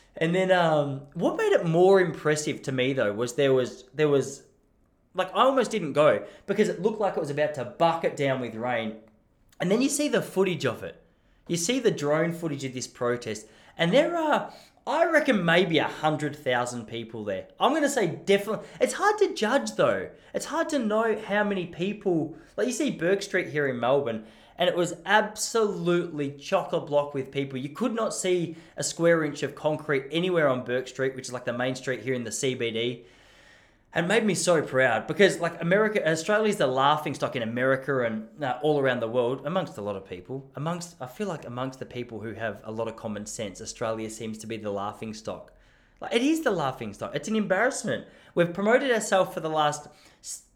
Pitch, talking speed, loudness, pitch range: 150 Hz, 210 wpm, -26 LUFS, 125-190 Hz